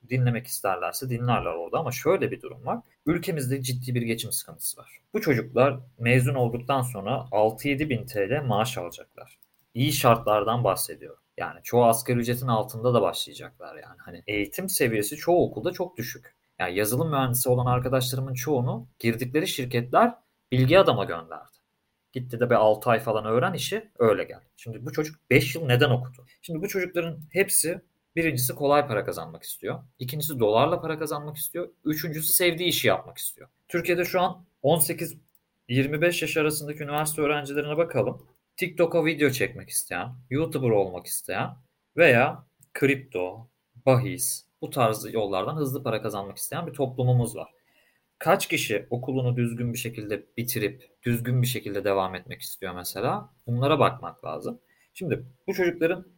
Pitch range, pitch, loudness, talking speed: 120-155 Hz, 130 Hz, -26 LUFS, 150 wpm